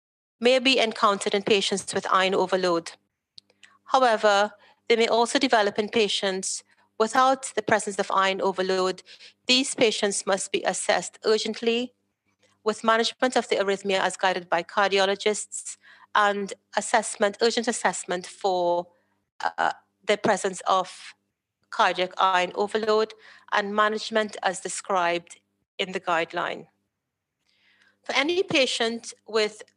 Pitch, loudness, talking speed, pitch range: 205 Hz, -24 LUFS, 120 wpm, 190-225 Hz